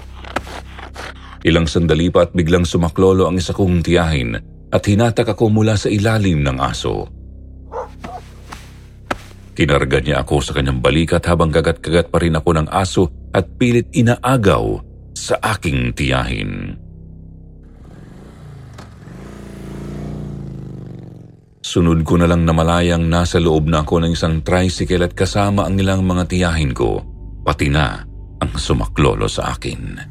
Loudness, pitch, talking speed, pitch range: -16 LUFS, 85 Hz, 125 wpm, 75-95 Hz